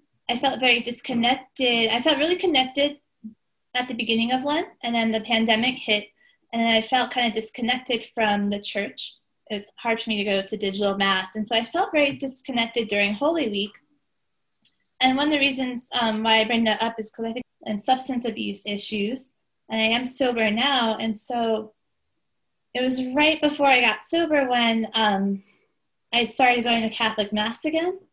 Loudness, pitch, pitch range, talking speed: -23 LUFS, 235 Hz, 220-260 Hz, 190 wpm